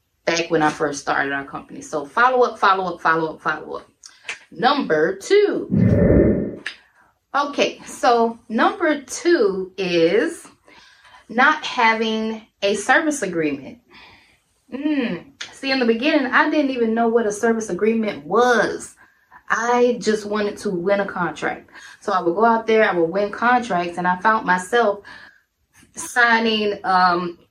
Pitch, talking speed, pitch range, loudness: 220 Hz, 140 wpm, 180-250 Hz, -19 LUFS